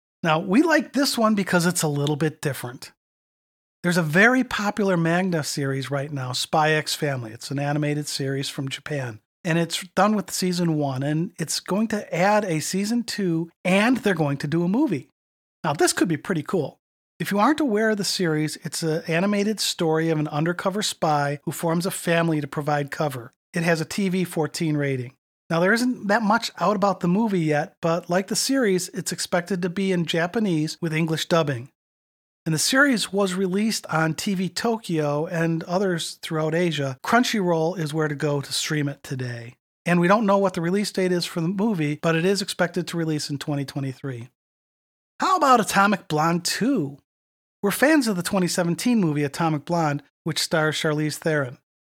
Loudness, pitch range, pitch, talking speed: -23 LUFS, 150-195 Hz, 170 Hz, 190 wpm